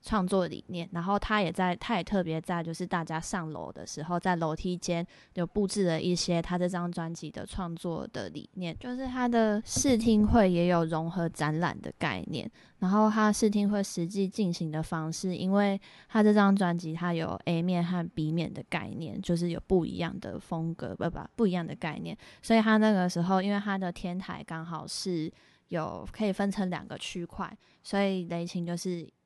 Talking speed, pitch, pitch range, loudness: 285 characters per minute, 180 Hz, 170-200 Hz, -30 LUFS